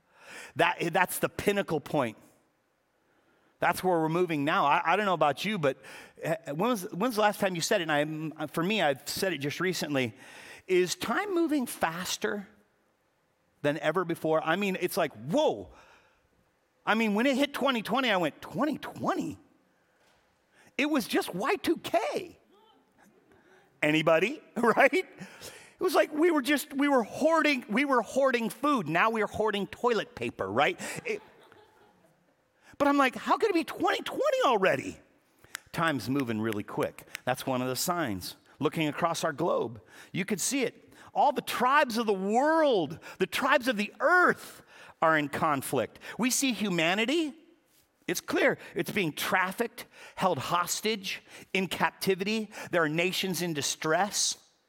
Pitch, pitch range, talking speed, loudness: 200 Hz, 165-275 Hz, 150 wpm, -28 LUFS